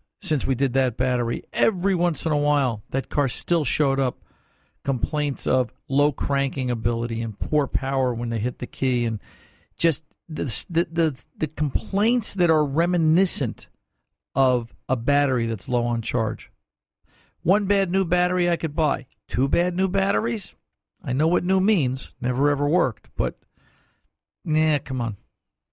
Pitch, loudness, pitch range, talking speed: 135 Hz, -23 LUFS, 120-165 Hz, 160 wpm